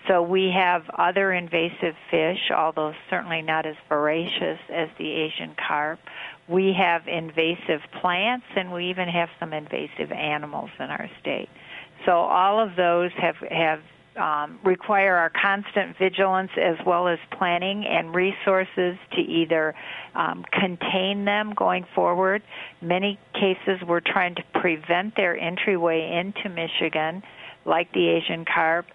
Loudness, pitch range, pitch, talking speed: -24 LUFS, 165-190 Hz, 175 Hz, 140 wpm